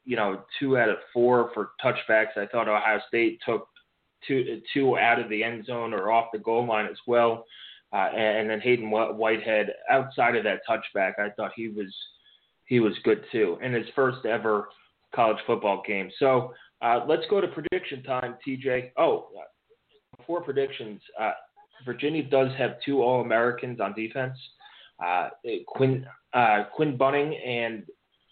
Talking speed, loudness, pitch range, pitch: 165 wpm, -26 LUFS, 110-140 Hz, 120 Hz